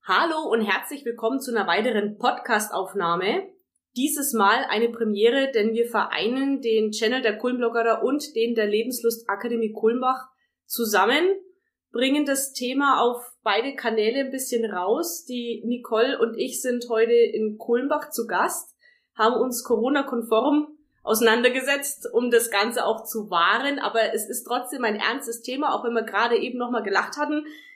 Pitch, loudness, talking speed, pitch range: 235 Hz, -23 LUFS, 150 wpm, 225-275 Hz